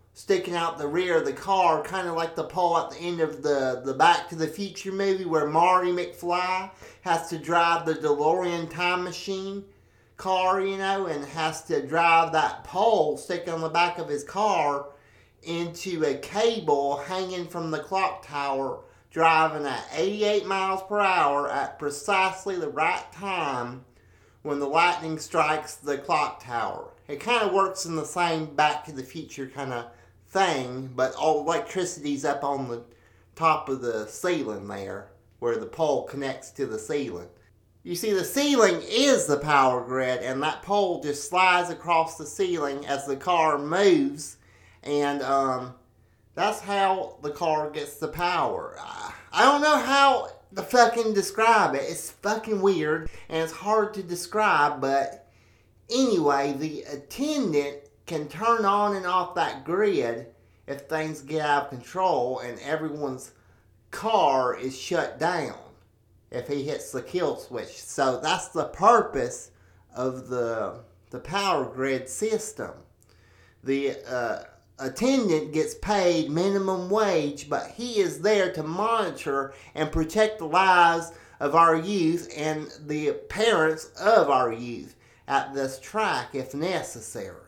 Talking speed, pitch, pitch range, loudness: 155 wpm, 160 Hz, 140-190 Hz, -25 LUFS